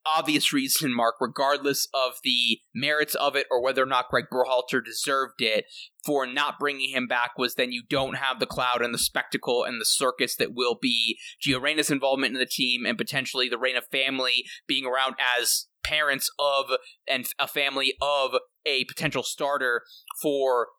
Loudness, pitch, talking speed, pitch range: -25 LUFS, 135 Hz, 180 wpm, 130-145 Hz